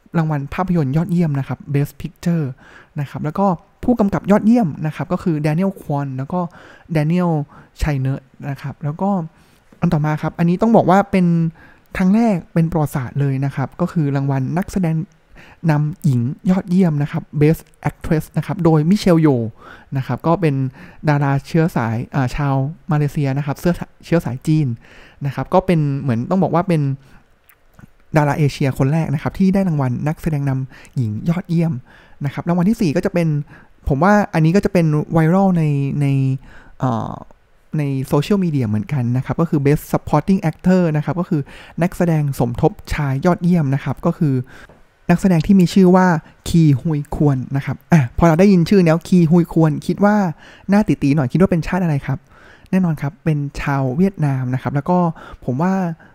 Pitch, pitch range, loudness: 155 Hz, 140-175 Hz, -18 LUFS